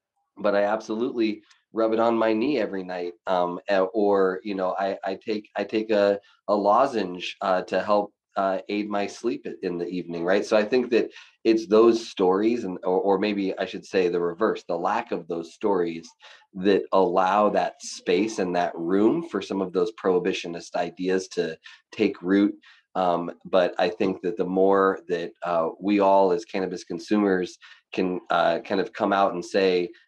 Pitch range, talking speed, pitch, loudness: 95-110 Hz, 185 wpm, 100 Hz, -24 LUFS